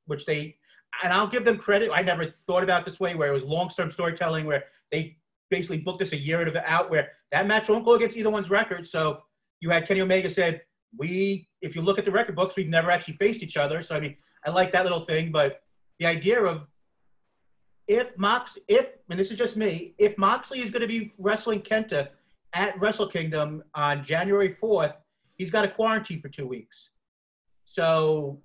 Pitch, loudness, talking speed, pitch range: 180 Hz, -25 LUFS, 205 wpm, 160-205 Hz